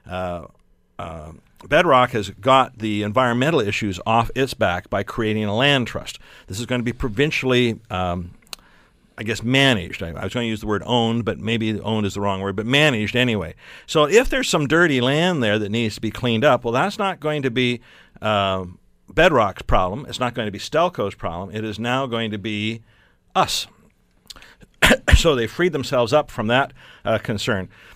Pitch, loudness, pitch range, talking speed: 115 Hz, -20 LUFS, 105-130 Hz, 195 wpm